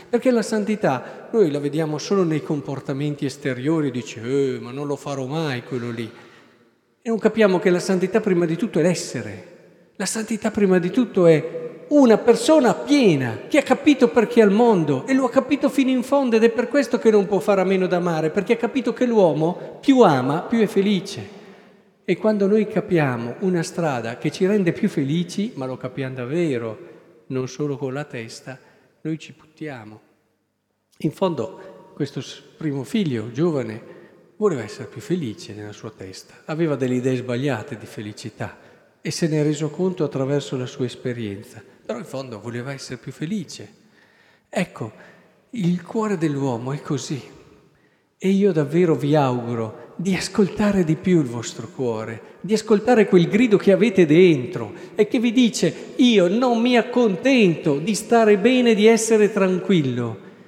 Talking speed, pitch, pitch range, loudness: 170 wpm, 170 Hz, 135-210 Hz, -20 LUFS